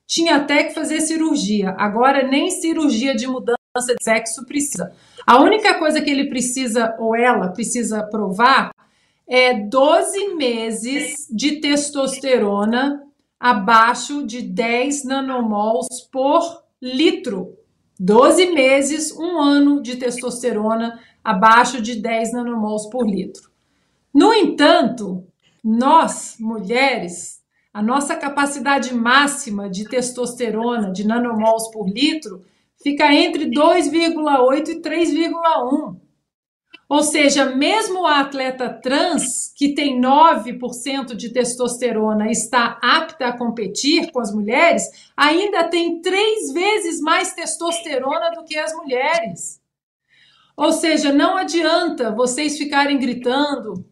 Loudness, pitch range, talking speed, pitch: -17 LUFS, 235-310 Hz, 110 wpm, 270 Hz